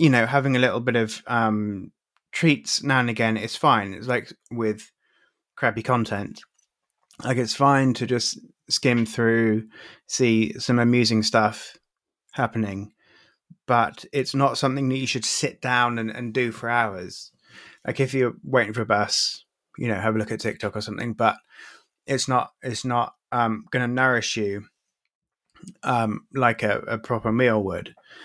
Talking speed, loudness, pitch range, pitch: 165 wpm, -23 LUFS, 110-130 Hz, 120 Hz